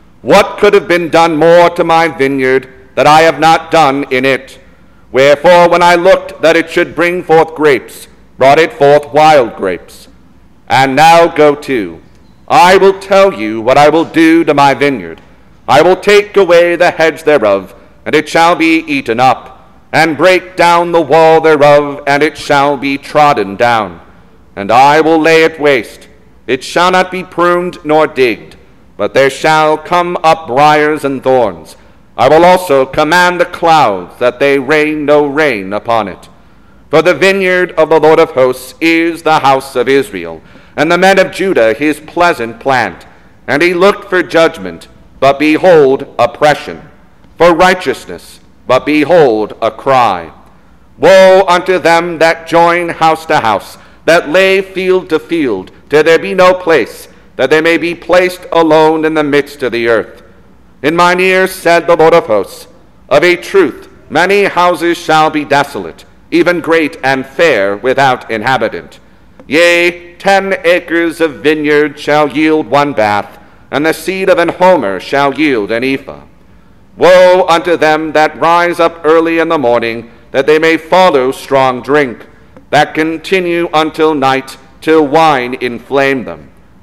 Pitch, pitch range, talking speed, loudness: 160 Hz, 140-175 Hz, 160 wpm, -9 LUFS